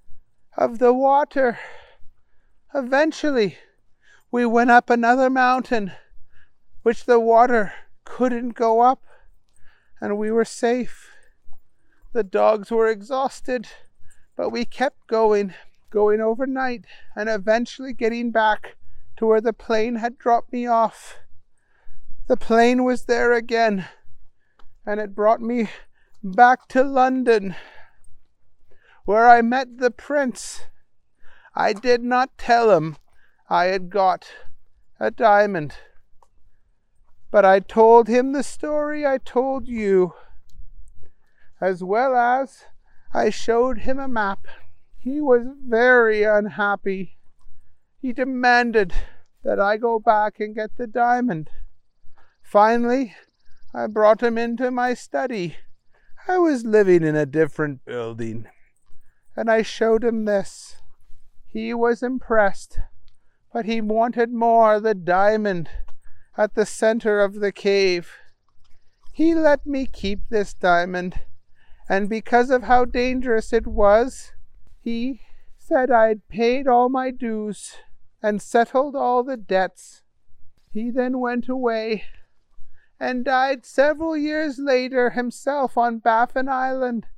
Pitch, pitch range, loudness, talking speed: 225 Hz, 195-245 Hz, -20 LUFS, 120 wpm